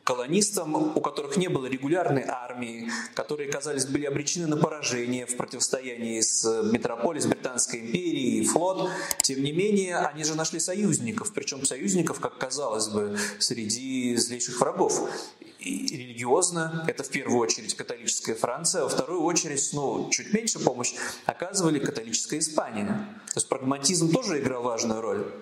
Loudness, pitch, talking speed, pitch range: -27 LUFS, 160 Hz, 150 wpm, 125-205 Hz